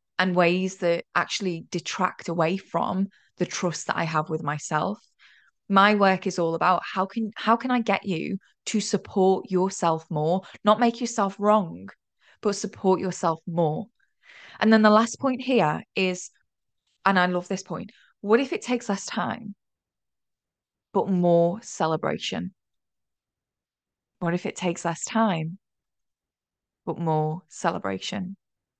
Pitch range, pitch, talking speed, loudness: 170-210 Hz, 185 Hz, 140 wpm, -25 LUFS